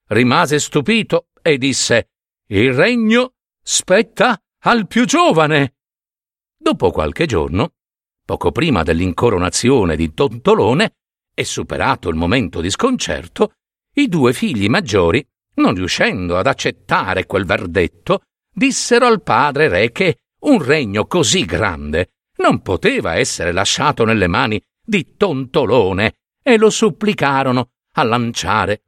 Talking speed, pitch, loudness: 115 wpm, 155 Hz, -15 LUFS